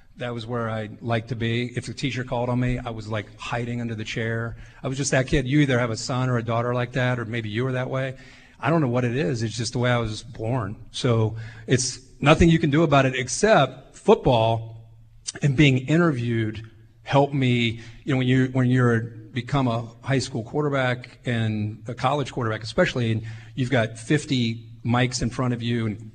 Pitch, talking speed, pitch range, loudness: 125 Hz, 220 wpm, 115-130 Hz, -24 LUFS